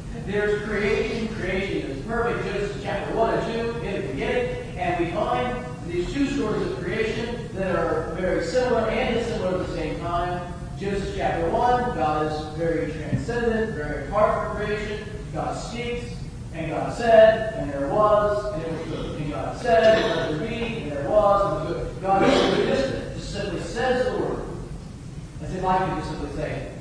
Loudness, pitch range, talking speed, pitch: -24 LUFS, 160-215 Hz, 190 wpm, 185 Hz